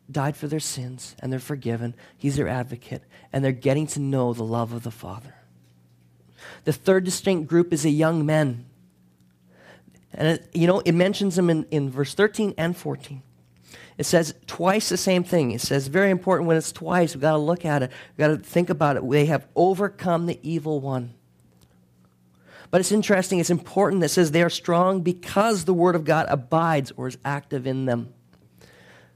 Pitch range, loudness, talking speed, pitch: 120-170 Hz, -23 LUFS, 195 wpm, 150 Hz